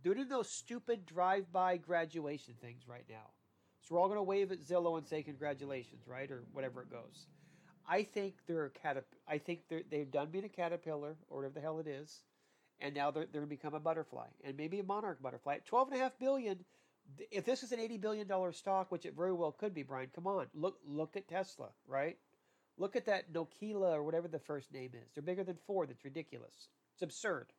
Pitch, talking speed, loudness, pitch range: 165 Hz, 220 wpm, -40 LUFS, 145-195 Hz